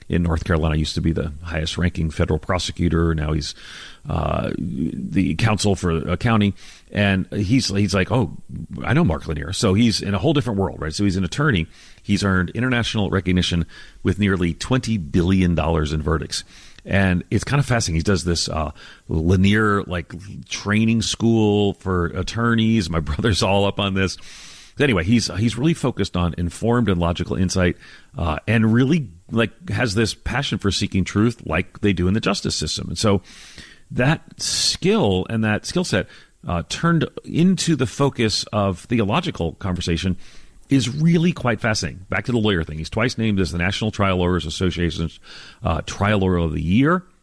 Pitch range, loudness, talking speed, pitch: 85-110 Hz, -21 LUFS, 175 wpm, 95 Hz